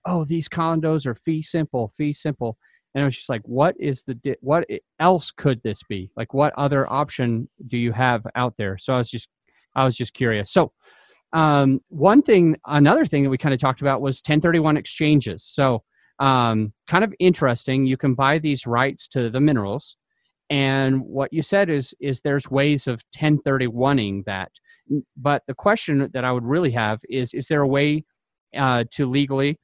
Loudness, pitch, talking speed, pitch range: -21 LUFS, 135 Hz, 190 wpm, 125-150 Hz